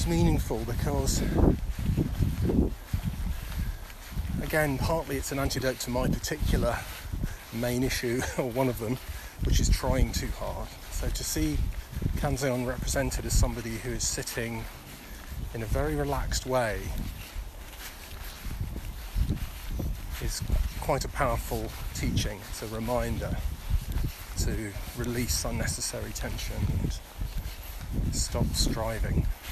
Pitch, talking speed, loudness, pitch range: 105 Hz, 105 wpm, -31 LUFS, 85-120 Hz